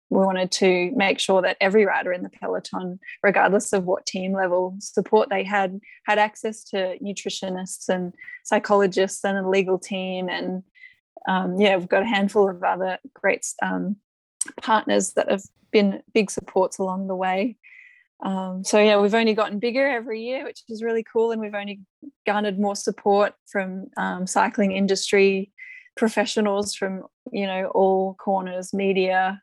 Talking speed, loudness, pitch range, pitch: 160 wpm, -23 LUFS, 190-215 Hz, 200 Hz